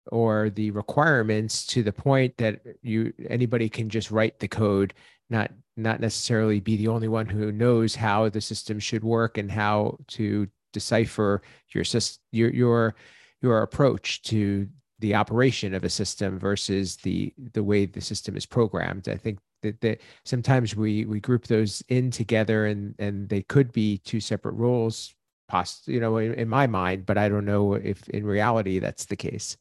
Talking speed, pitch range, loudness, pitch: 170 wpm, 105-115 Hz, -25 LUFS, 110 Hz